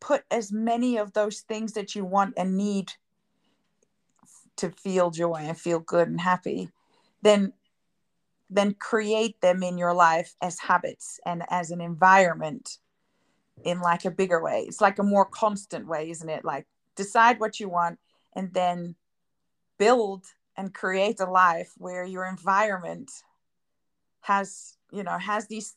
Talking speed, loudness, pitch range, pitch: 150 wpm, -25 LUFS, 175-210 Hz, 190 Hz